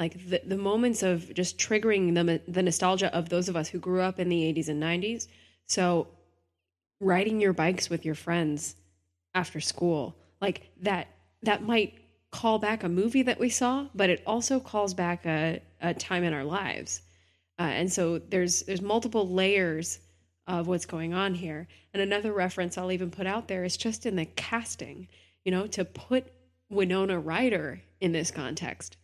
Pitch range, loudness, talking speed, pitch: 160-195 Hz, -29 LUFS, 180 wpm, 180 Hz